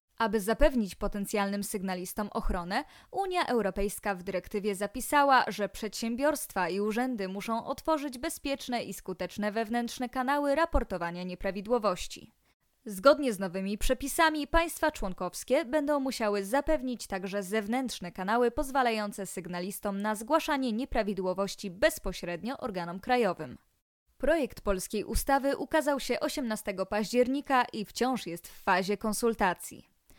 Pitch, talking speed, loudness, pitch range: 225 Hz, 110 wpm, -31 LUFS, 200-270 Hz